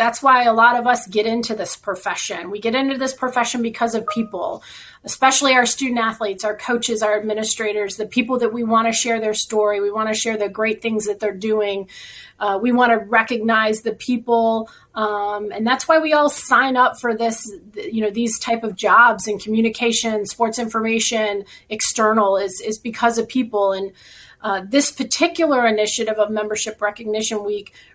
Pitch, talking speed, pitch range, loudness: 225 Hz, 185 wpm, 215-235 Hz, -17 LUFS